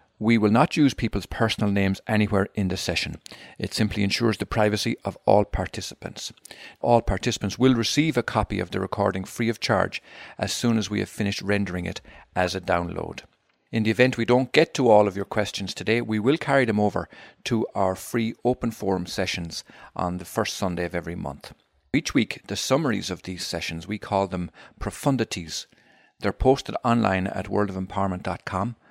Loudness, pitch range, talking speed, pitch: -24 LUFS, 95-115 Hz, 185 wpm, 100 Hz